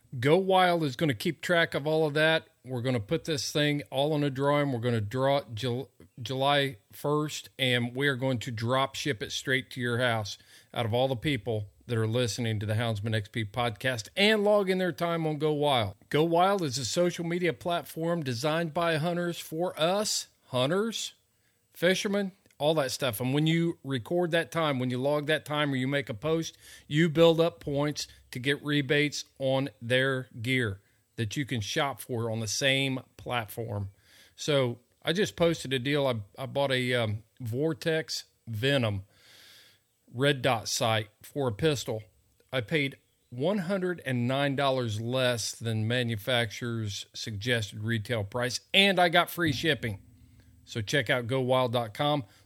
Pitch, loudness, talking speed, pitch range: 135 Hz, -29 LUFS, 170 wpm, 120-155 Hz